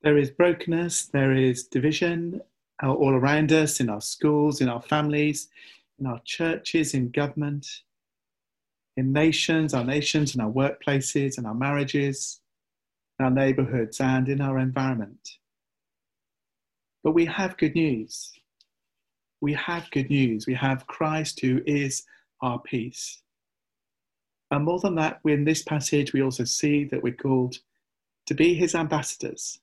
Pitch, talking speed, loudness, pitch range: 145 Hz, 140 wpm, -25 LUFS, 130-155 Hz